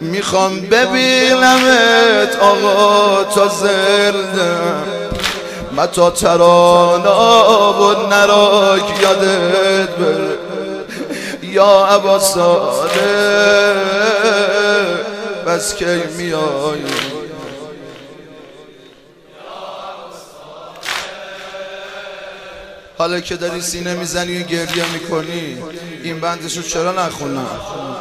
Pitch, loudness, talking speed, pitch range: 195 Hz, -13 LUFS, 60 wpm, 175-205 Hz